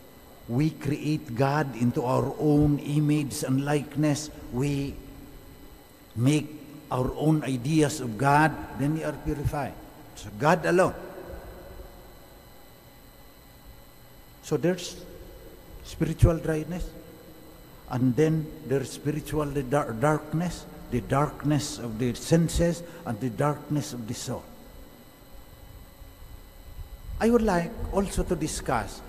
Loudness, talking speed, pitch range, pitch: -27 LUFS, 105 wpm, 130-155 Hz, 145 Hz